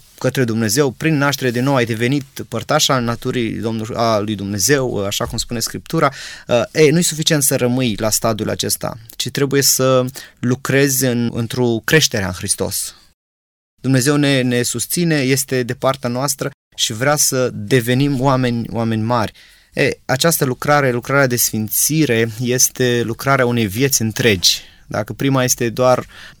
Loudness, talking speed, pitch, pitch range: -16 LUFS, 150 wpm, 125 Hz, 115-140 Hz